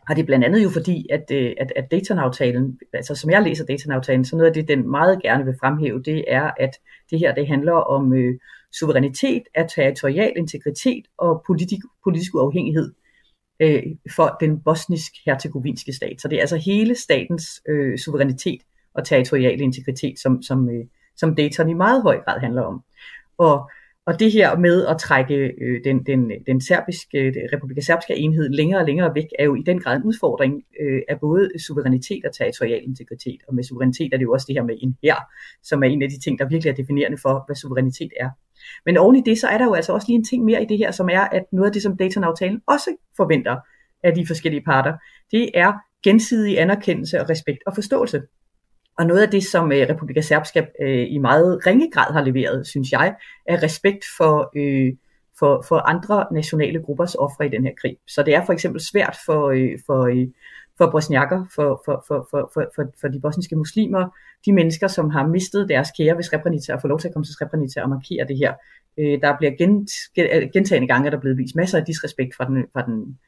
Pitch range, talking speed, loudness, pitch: 135-175 Hz, 210 wpm, -19 LUFS, 155 Hz